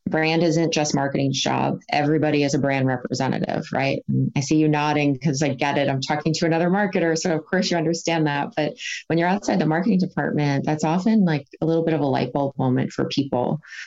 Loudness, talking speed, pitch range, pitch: -22 LUFS, 215 wpm, 145-165 Hz, 155 Hz